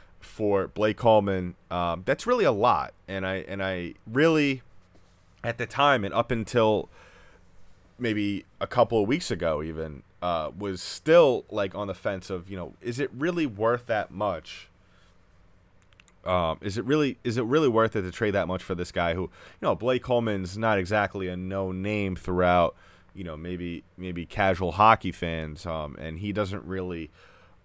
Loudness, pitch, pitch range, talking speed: -26 LUFS, 95 Hz, 90-105 Hz, 175 wpm